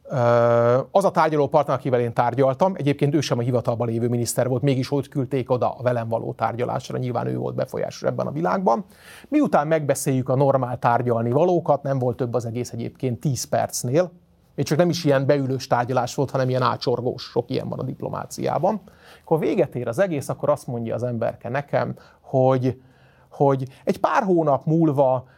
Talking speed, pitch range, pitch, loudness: 180 wpm, 120-145 Hz, 130 Hz, -22 LUFS